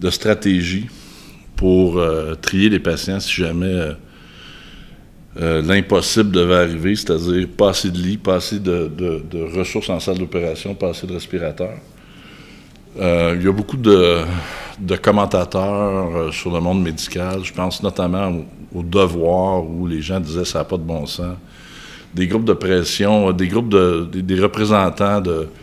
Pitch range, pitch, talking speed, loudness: 85-95 Hz, 90 Hz, 170 wpm, -18 LUFS